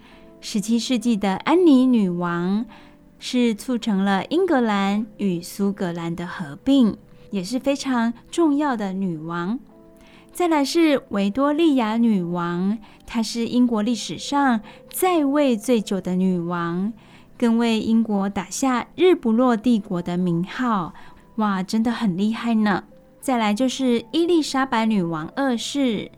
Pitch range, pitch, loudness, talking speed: 195-255 Hz, 225 Hz, -21 LUFS, 200 characters per minute